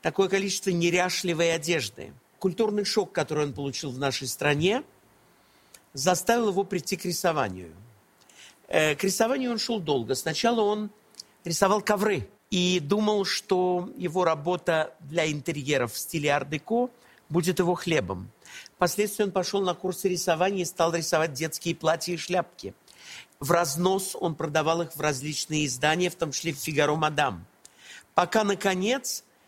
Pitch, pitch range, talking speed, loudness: 175 Hz, 155-195 Hz, 140 wpm, -26 LUFS